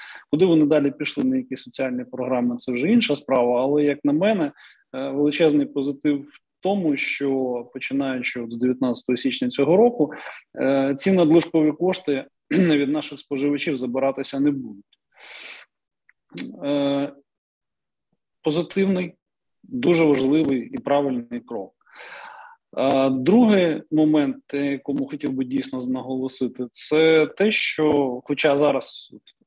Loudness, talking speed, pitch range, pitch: -22 LUFS, 110 wpm, 130-155 Hz, 140 Hz